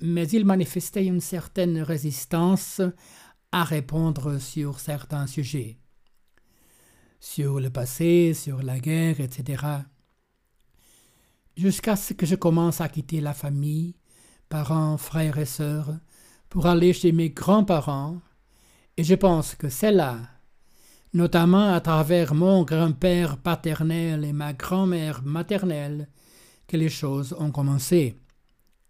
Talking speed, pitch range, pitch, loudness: 120 wpm, 145-175 Hz, 160 Hz, -24 LUFS